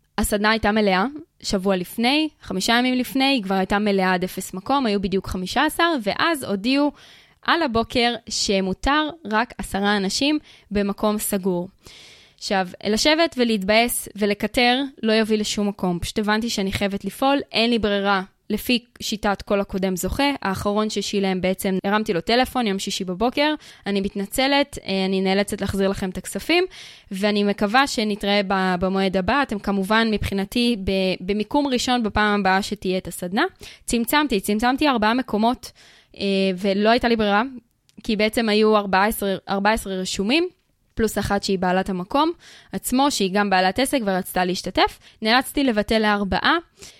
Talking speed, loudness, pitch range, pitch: 140 wpm, -21 LUFS, 195-245 Hz, 210 Hz